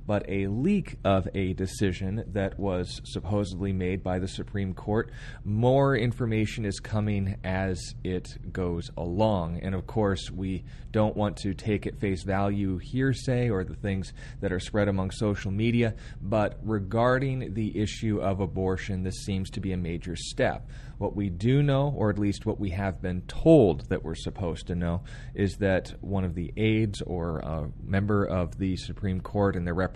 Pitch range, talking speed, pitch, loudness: 95-110 Hz, 180 wpm, 100 Hz, -28 LUFS